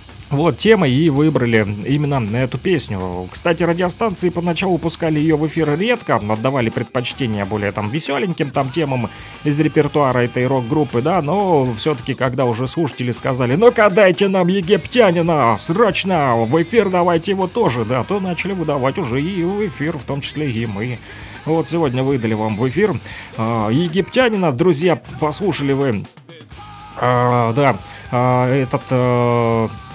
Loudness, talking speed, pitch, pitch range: -17 LUFS, 140 wpm, 140 Hz, 120-170 Hz